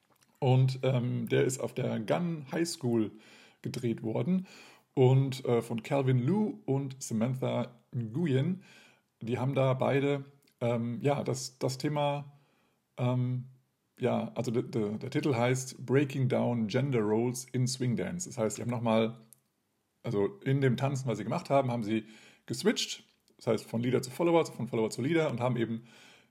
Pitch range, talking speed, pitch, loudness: 115-140 Hz, 165 wpm, 125 Hz, -31 LUFS